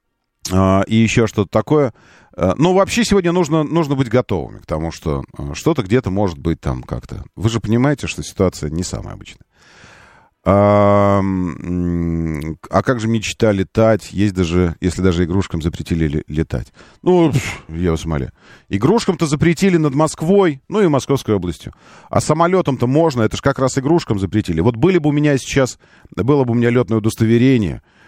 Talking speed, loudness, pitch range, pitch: 165 wpm, -17 LUFS, 90-140 Hz, 110 Hz